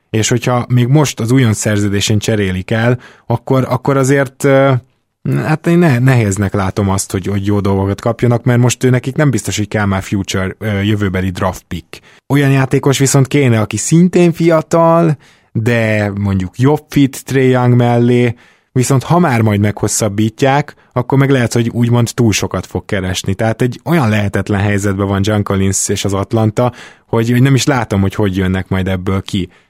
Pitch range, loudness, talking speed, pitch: 100-130 Hz, -13 LUFS, 175 wpm, 115 Hz